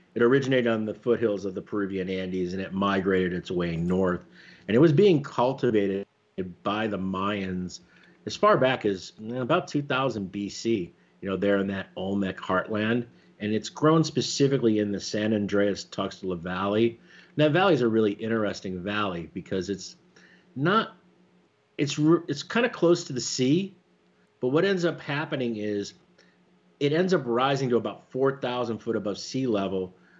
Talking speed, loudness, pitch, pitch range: 165 wpm, -26 LUFS, 105 Hz, 95-130 Hz